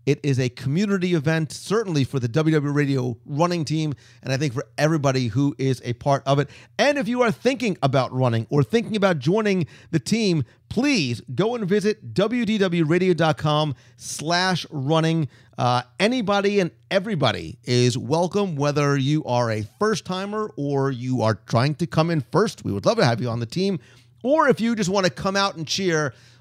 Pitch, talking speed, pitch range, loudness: 150 Hz, 180 wpm, 130-195 Hz, -22 LUFS